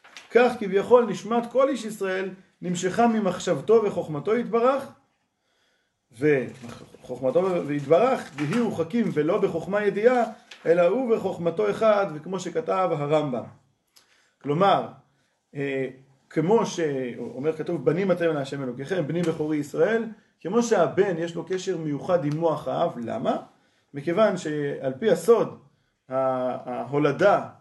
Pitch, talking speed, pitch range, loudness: 175 Hz, 110 wpm, 150-220 Hz, -24 LUFS